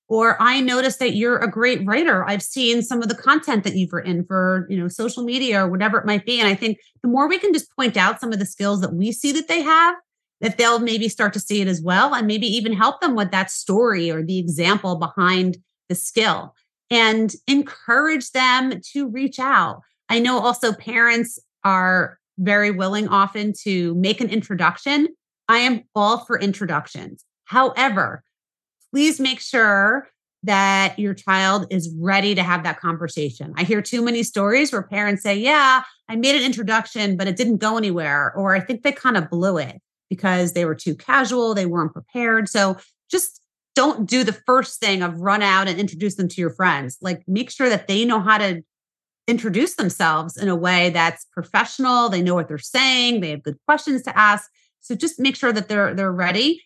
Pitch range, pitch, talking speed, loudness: 185-245 Hz, 210 Hz, 200 wpm, -19 LUFS